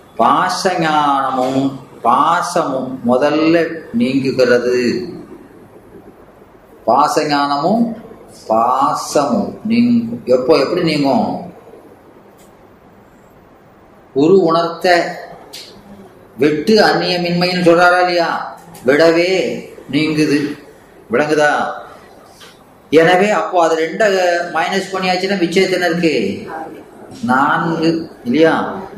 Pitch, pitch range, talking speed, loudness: 165 Hz, 150-185 Hz, 55 wpm, -14 LUFS